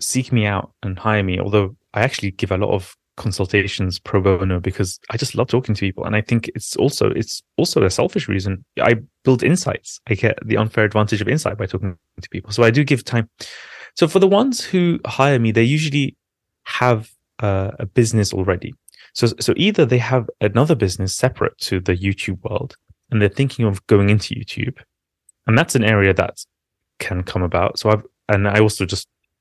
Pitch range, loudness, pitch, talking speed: 100-125 Hz, -19 LUFS, 110 Hz, 200 wpm